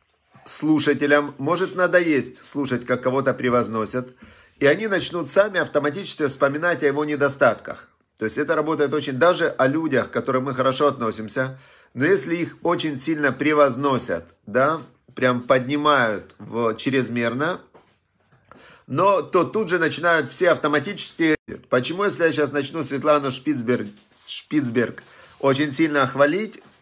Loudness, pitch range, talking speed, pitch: -21 LUFS, 130-160 Hz, 130 wpm, 145 Hz